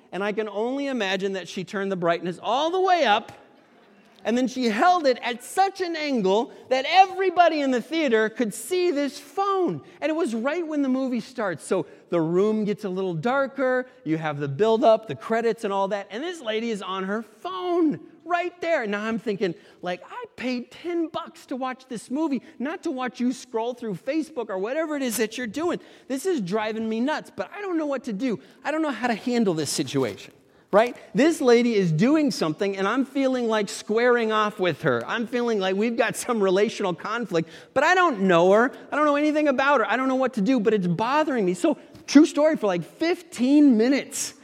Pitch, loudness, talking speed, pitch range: 245 Hz, -24 LUFS, 220 wpm, 205-295 Hz